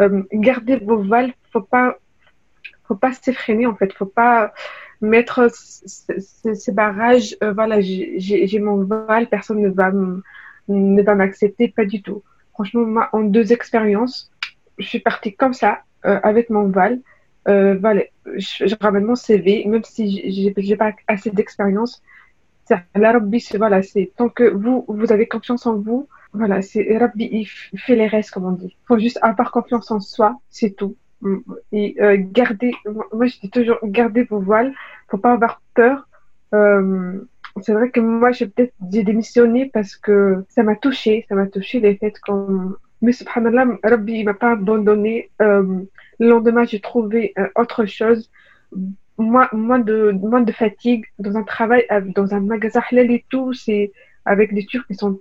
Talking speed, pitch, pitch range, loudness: 180 wpm, 220 Hz, 205-235 Hz, -17 LUFS